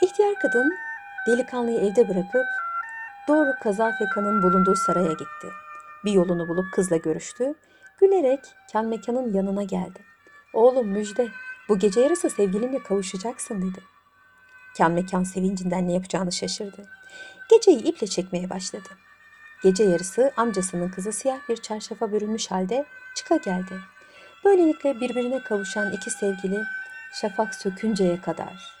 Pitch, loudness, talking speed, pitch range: 220 Hz, -24 LUFS, 120 wpm, 190-275 Hz